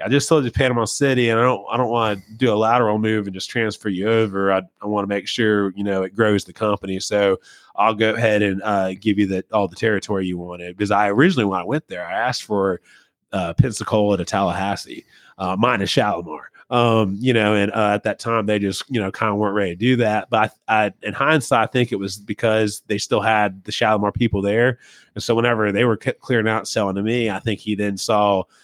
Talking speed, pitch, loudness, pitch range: 245 wpm, 105 Hz, -20 LUFS, 100-115 Hz